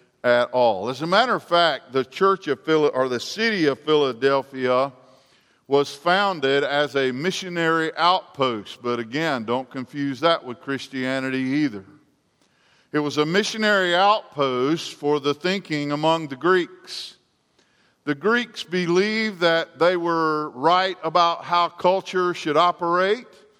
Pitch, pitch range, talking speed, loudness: 155 Hz, 135-180 Hz, 135 wpm, -22 LUFS